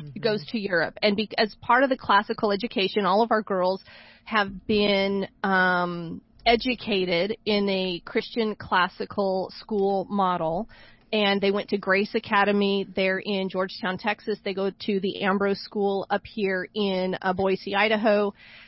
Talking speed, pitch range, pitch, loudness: 150 wpm, 190-210 Hz, 200 Hz, -25 LUFS